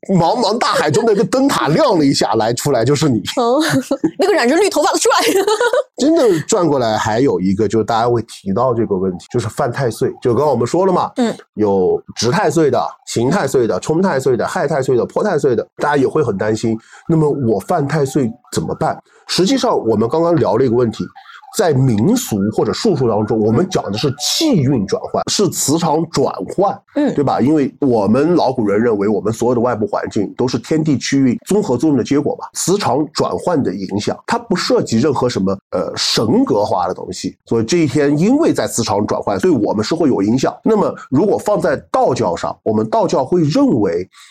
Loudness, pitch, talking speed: -15 LUFS, 155 Hz, 310 characters per minute